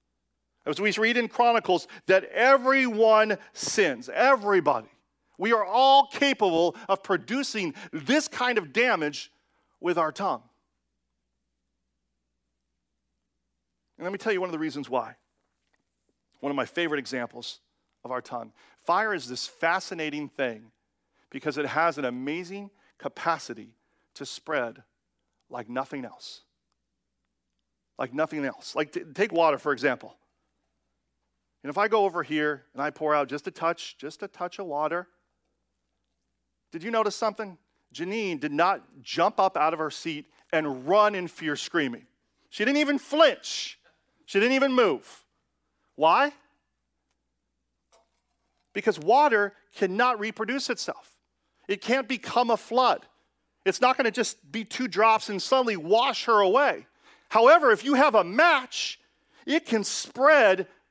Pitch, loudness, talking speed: 175 Hz, -25 LUFS, 140 wpm